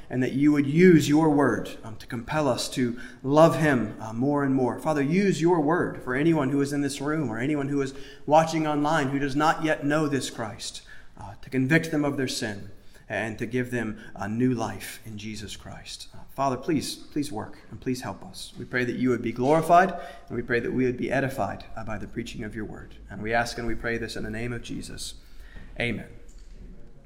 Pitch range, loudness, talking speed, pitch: 115-150 Hz, -25 LUFS, 230 wpm, 130 Hz